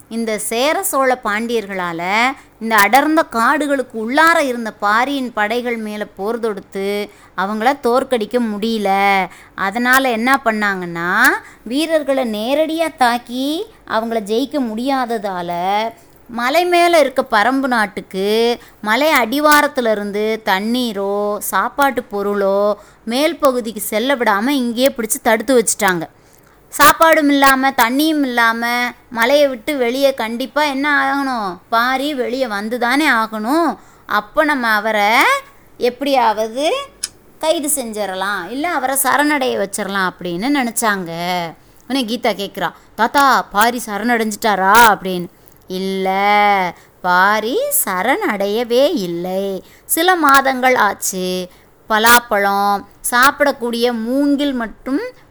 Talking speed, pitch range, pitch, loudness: 95 wpm, 205-275 Hz, 235 Hz, -16 LUFS